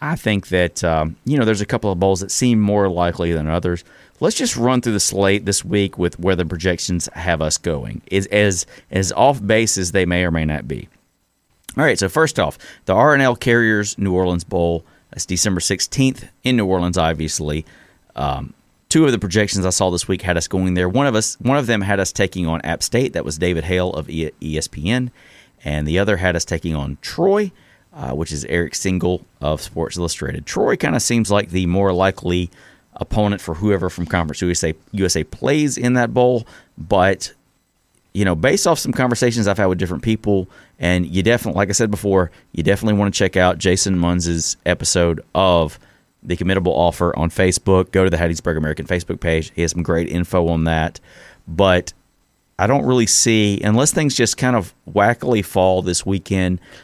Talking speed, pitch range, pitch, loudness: 200 wpm, 85-105 Hz, 95 Hz, -18 LUFS